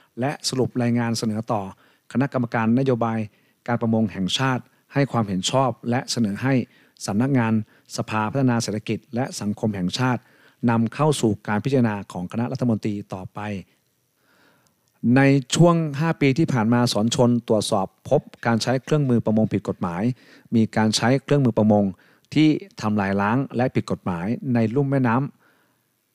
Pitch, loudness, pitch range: 120 Hz, -22 LUFS, 110-130 Hz